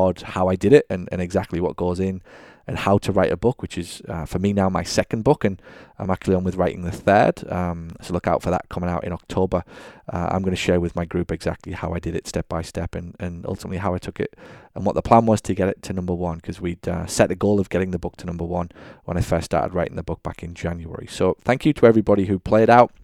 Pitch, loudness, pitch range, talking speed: 90 Hz, -22 LUFS, 85-100 Hz, 280 wpm